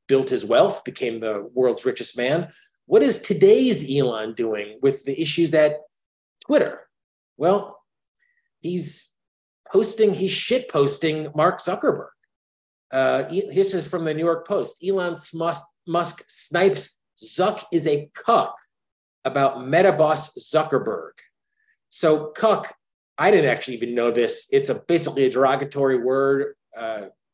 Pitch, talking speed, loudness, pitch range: 165 Hz, 130 wpm, -22 LUFS, 135-195 Hz